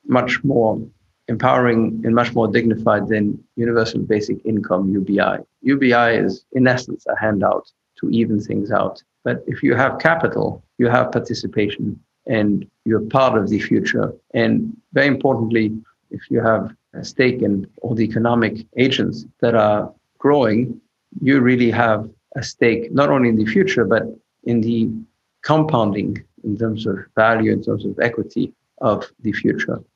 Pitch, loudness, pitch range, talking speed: 115 Hz, -18 LUFS, 110-120 Hz, 155 wpm